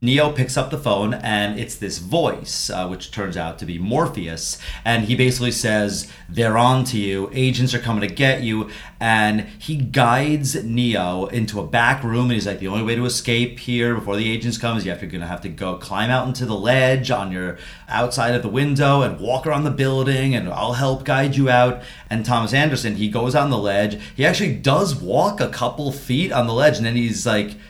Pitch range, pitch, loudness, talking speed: 105-130 Hz, 120 Hz, -20 LUFS, 220 wpm